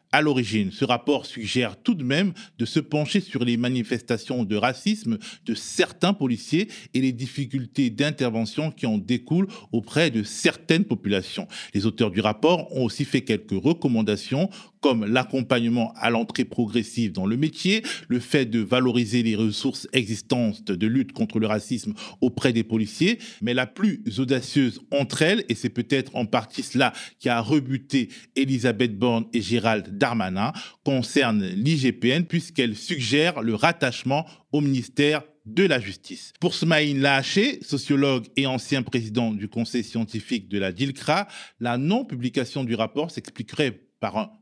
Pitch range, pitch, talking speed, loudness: 115-150 Hz, 130 Hz, 155 wpm, -24 LUFS